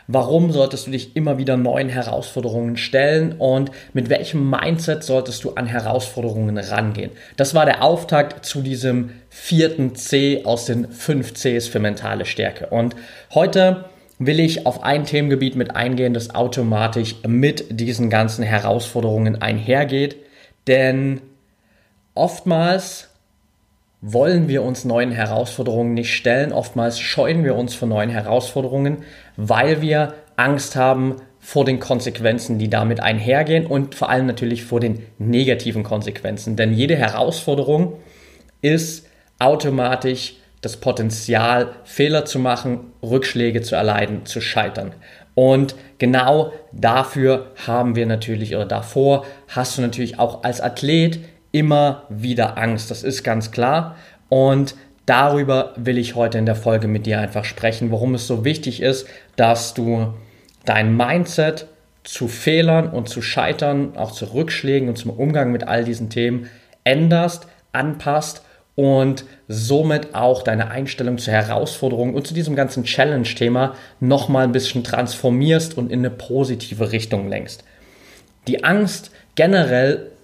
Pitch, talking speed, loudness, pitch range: 125 Hz, 135 wpm, -19 LUFS, 115-140 Hz